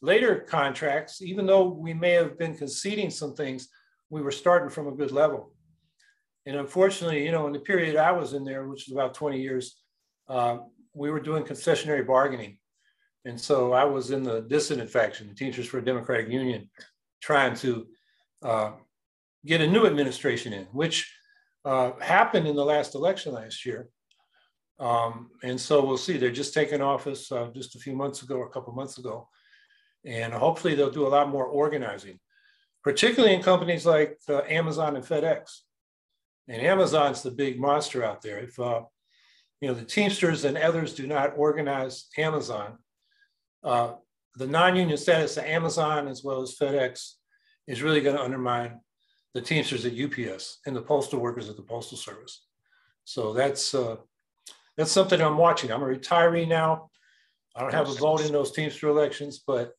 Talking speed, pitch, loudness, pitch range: 175 wpm, 145 Hz, -26 LUFS, 130-160 Hz